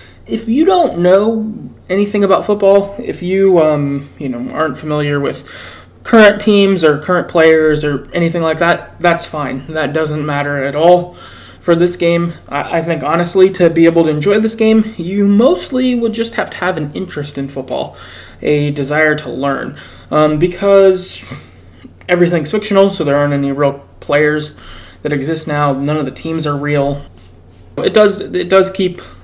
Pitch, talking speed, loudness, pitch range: 165 Hz, 170 wpm, -13 LUFS, 145-190 Hz